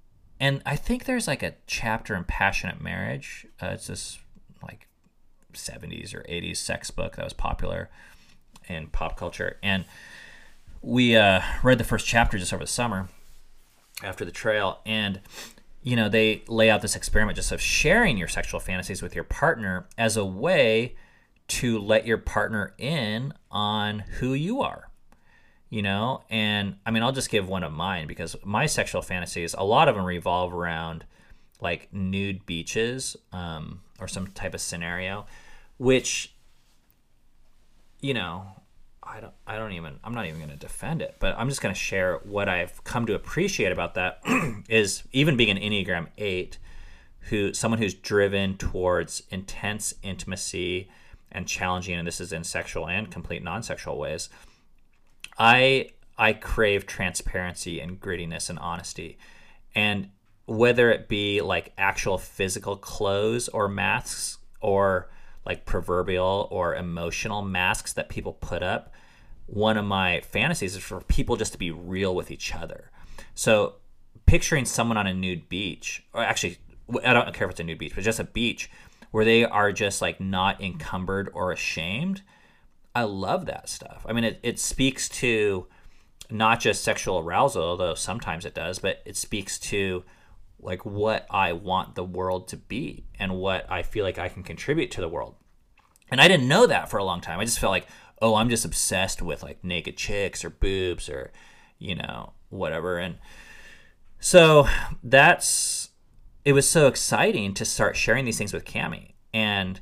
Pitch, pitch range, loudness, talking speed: 100 Hz, 90-110 Hz, -25 LUFS, 165 wpm